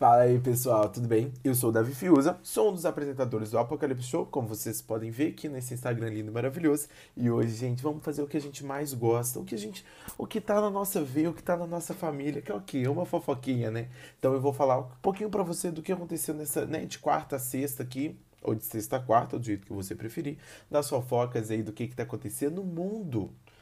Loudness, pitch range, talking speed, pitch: -30 LUFS, 115-155 Hz, 250 wpm, 135 Hz